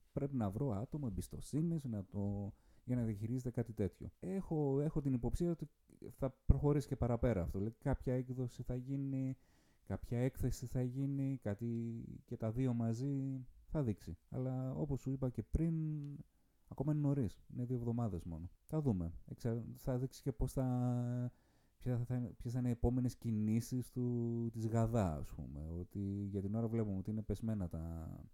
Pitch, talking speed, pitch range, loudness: 120 Hz, 165 wpm, 105-135 Hz, -40 LUFS